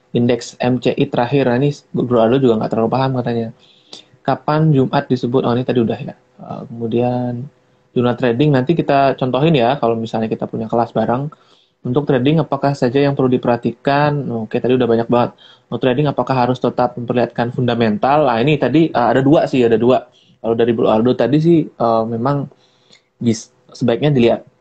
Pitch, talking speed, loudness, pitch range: 125 Hz, 170 wpm, -16 LUFS, 120-140 Hz